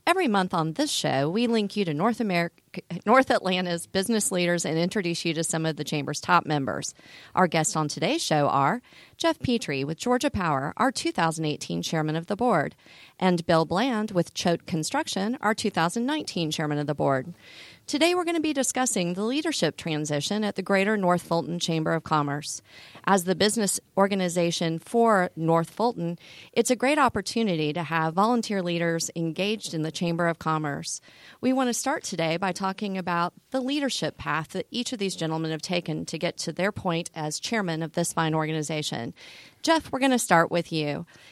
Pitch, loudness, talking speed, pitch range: 175 Hz, -26 LUFS, 185 wpm, 160-215 Hz